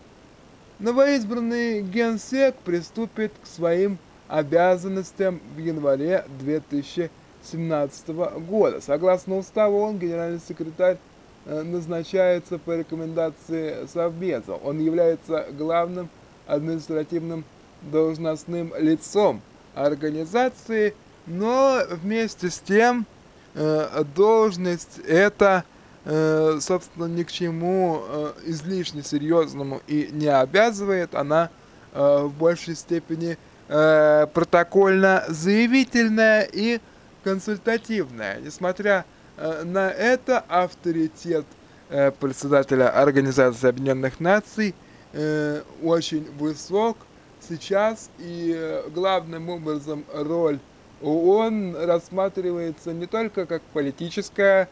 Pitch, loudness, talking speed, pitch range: 170 Hz, -23 LUFS, 75 wpm, 155-195 Hz